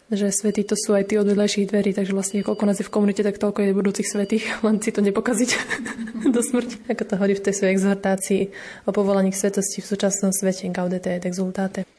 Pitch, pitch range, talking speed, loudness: 205 Hz, 195-215 Hz, 215 wpm, -22 LUFS